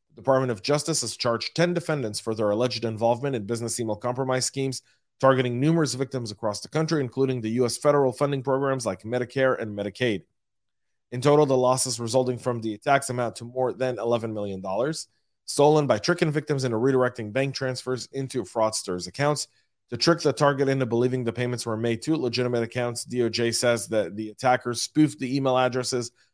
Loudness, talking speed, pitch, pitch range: -25 LUFS, 180 wpm, 125 Hz, 115-135 Hz